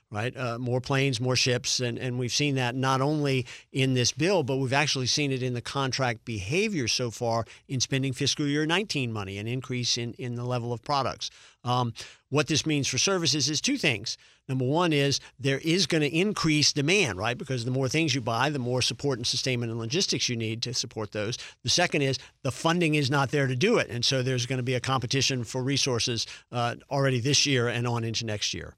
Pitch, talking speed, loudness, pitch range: 130 Hz, 225 wpm, -26 LUFS, 120-145 Hz